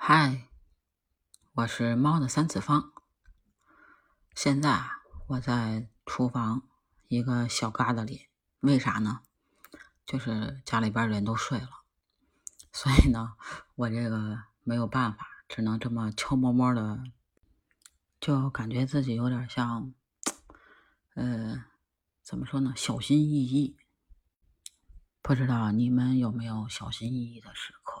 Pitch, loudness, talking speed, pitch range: 120 Hz, -29 LUFS, 180 characters per minute, 110-130 Hz